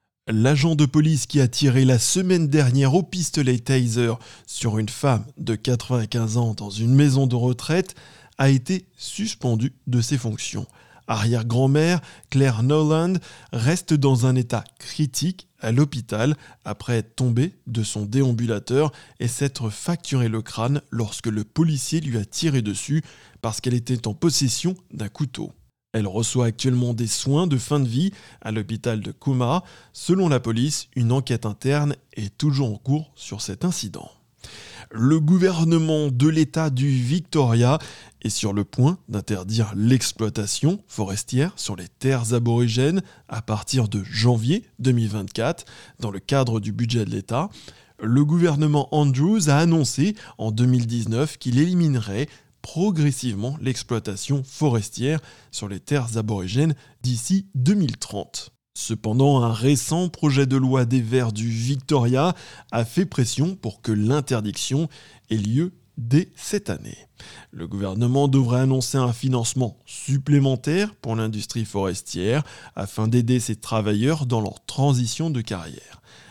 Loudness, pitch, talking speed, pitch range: -22 LUFS, 130 Hz, 140 wpm, 115-150 Hz